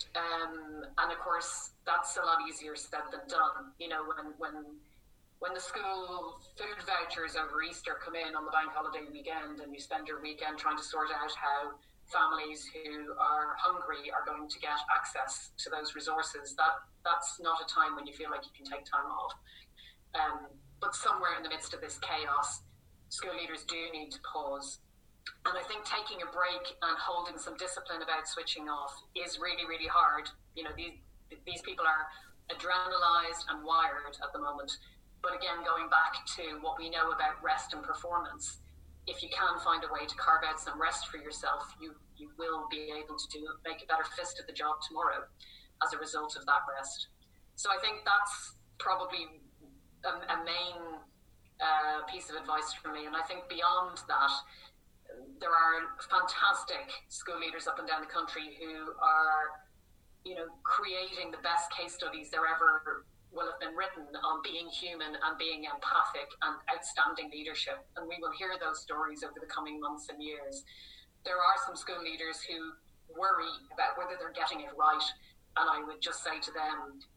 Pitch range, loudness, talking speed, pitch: 150-170 Hz, -34 LUFS, 185 wpm, 160 Hz